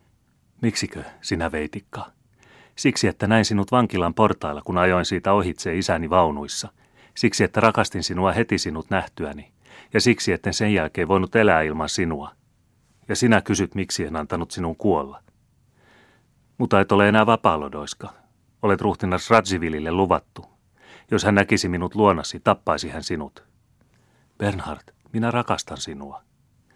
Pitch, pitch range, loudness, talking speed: 100 Hz, 90-110 Hz, -22 LUFS, 135 wpm